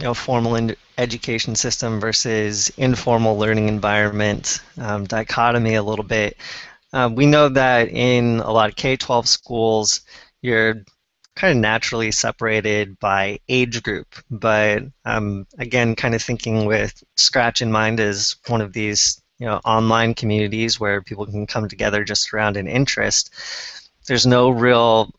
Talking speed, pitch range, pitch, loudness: 150 wpm, 105-120 Hz, 115 Hz, -18 LUFS